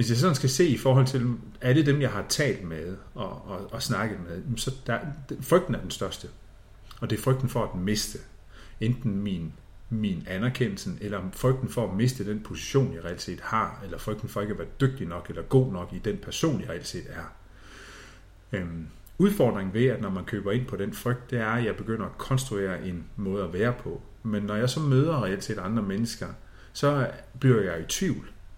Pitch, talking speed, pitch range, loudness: 110 Hz, 215 wpm, 95-130 Hz, -28 LUFS